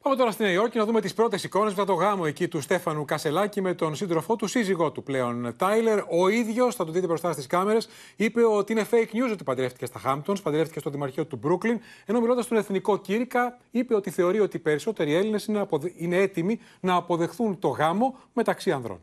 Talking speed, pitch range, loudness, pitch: 220 wpm, 165-220 Hz, -26 LUFS, 195 Hz